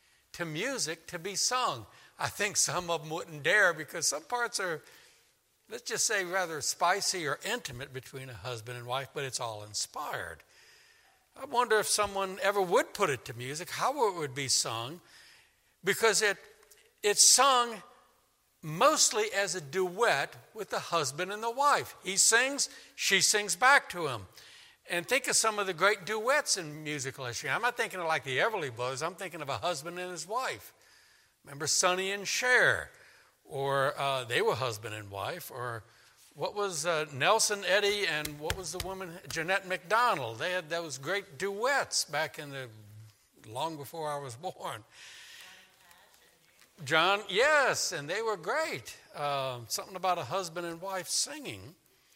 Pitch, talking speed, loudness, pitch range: 185 Hz, 170 wpm, -30 LUFS, 145-215 Hz